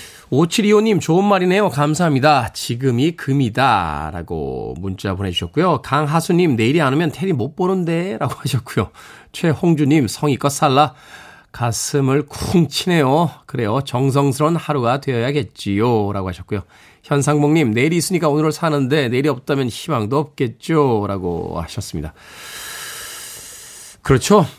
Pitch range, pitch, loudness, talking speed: 120-160 Hz, 145 Hz, -18 LUFS, 310 characters per minute